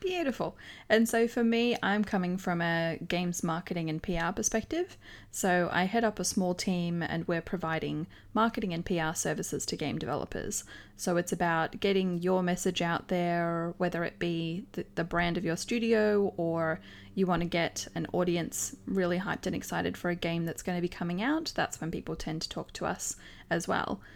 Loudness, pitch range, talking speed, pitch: -31 LUFS, 170-200 Hz, 190 wpm, 175 Hz